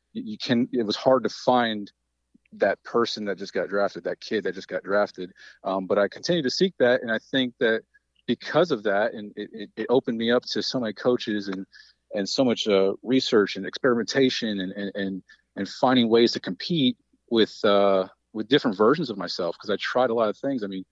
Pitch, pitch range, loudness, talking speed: 110 Hz, 100-130 Hz, -24 LUFS, 215 wpm